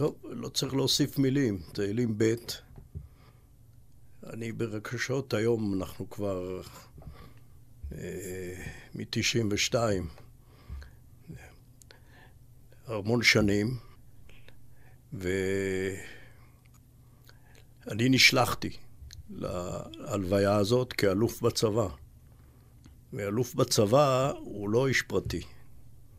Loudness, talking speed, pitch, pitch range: -29 LUFS, 65 wpm, 115 Hz, 100-125 Hz